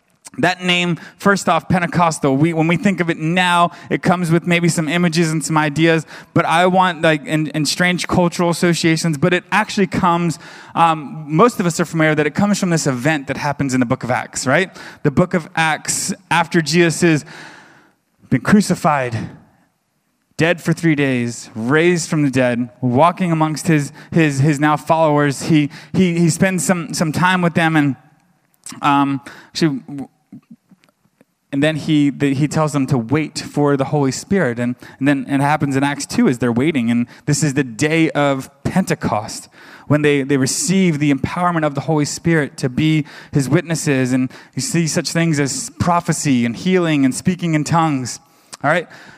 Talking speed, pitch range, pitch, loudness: 180 wpm, 145-175 Hz, 160 Hz, -17 LUFS